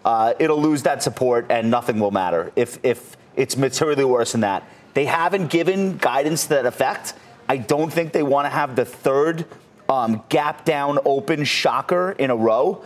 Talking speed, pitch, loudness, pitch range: 185 wpm, 145 Hz, -20 LUFS, 125-165 Hz